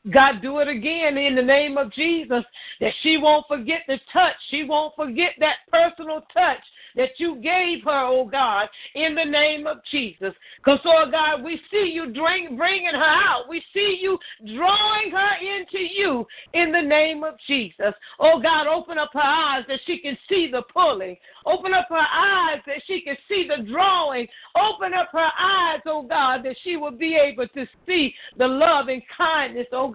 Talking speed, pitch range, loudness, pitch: 190 wpm, 275-345 Hz, -21 LUFS, 310 Hz